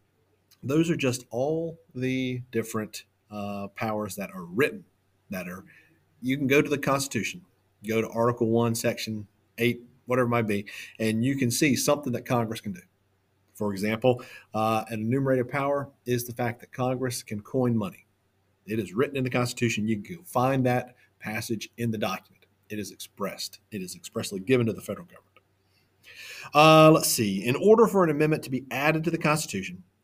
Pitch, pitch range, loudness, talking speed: 120 Hz, 105-135 Hz, -26 LUFS, 180 wpm